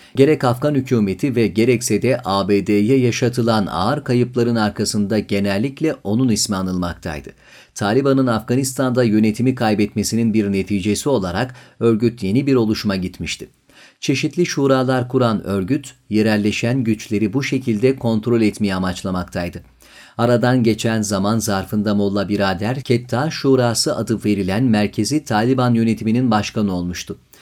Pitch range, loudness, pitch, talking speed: 100-125 Hz, -18 LUFS, 110 Hz, 115 wpm